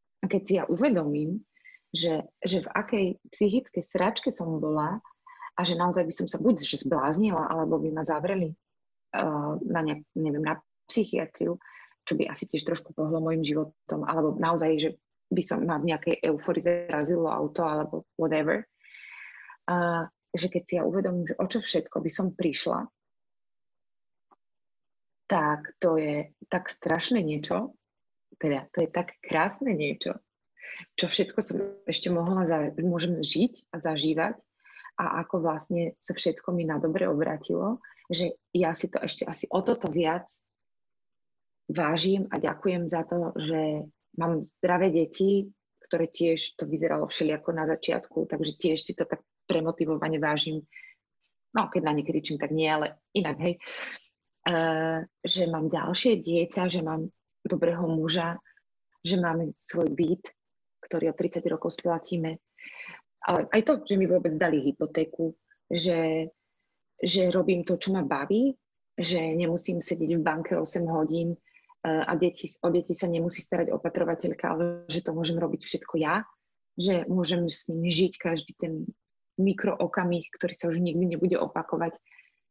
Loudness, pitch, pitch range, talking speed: -28 LUFS, 170 Hz, 160-185 Hz, 150 wpm